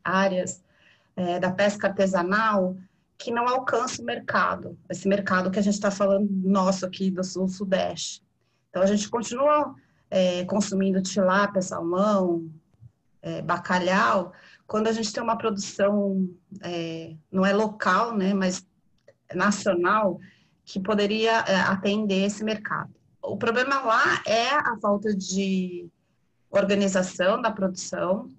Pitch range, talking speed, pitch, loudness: 185-210 Hz, 125 wpm, 195 Hz, -25 LUFS